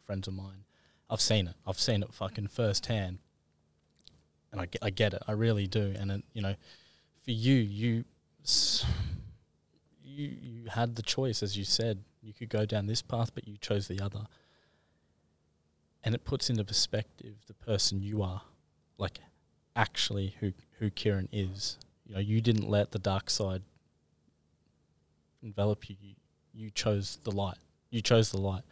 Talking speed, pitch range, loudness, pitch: 170 wpm, 80-110 Hz, -32 LUFS, 100 Hz